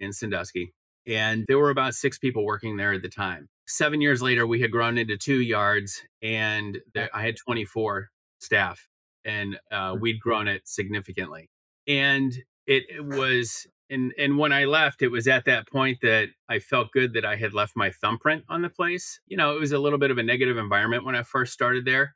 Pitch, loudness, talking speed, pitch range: 120 Hz, -24 LUFS, 205 wpm, 105-135 Hz